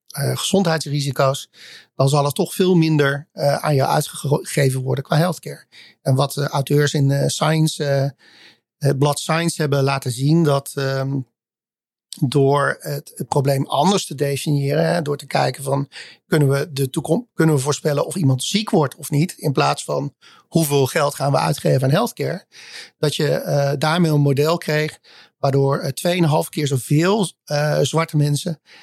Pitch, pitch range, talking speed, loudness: 145 Hz, 140-160 Hz, 170 wpm, -19 LUFS